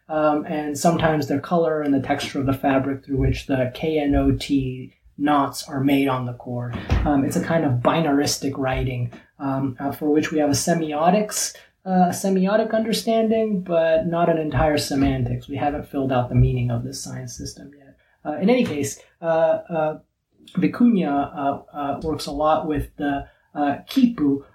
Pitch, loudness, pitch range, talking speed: 145 Hz, -22 LUFS, 135-160 Hz, 175 wpm